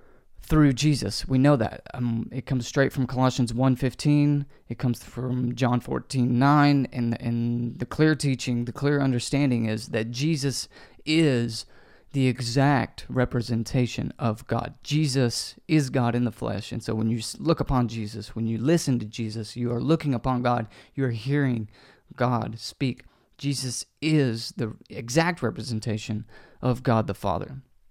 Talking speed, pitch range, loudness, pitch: 155 wpm, 115-140 Hz, -25 LUFS, 125 Hz